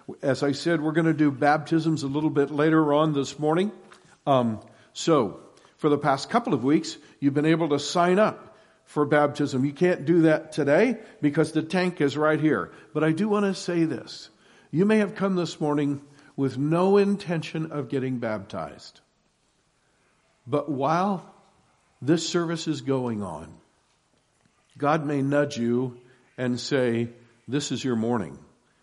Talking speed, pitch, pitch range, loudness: 160 wpm, 150 Hz, 140-170 Hz, -25 LUFS